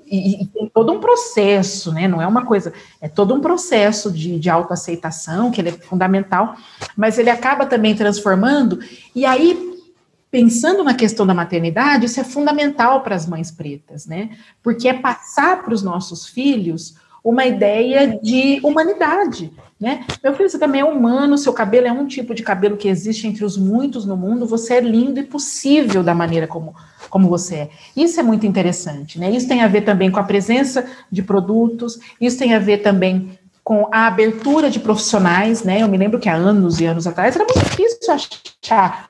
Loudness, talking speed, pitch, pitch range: -16 LUFS, 190 wpm, 220 Hz, 190-260 Hz